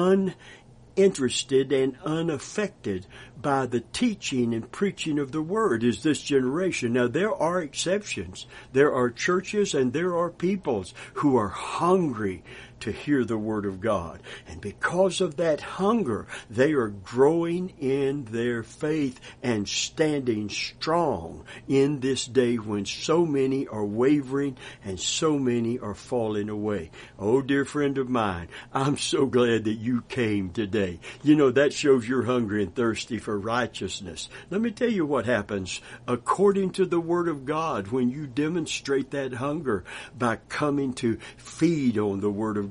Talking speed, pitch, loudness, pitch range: 155 wpm, 130 Hz, -26 LUFS, 115-155 Hz